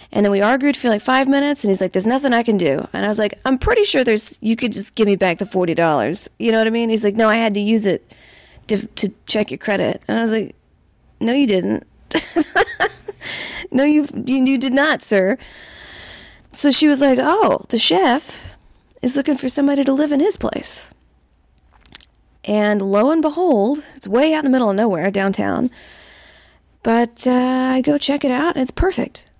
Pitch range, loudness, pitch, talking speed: 210-285 Hz, -17 LUFS, 250 Hz, 210 wpm